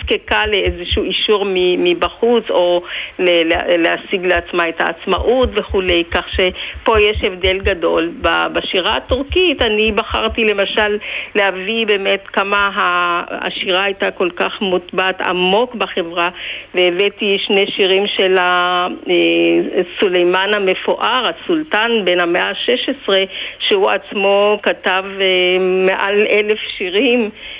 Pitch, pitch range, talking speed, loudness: 195 Hz, 180-210 Hz, 100 wpm, -15 LUFS